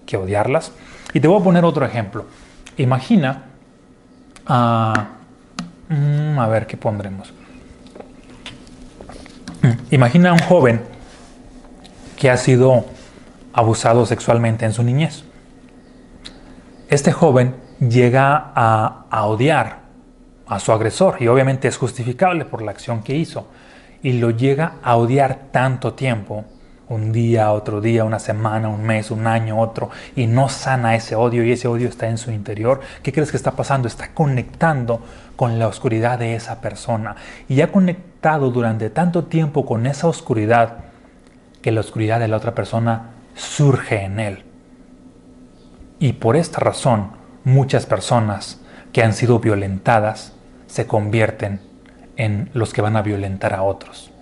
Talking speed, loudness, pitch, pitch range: 140 wpm, -18 LUFS, 120 Hz, 110-135 Hz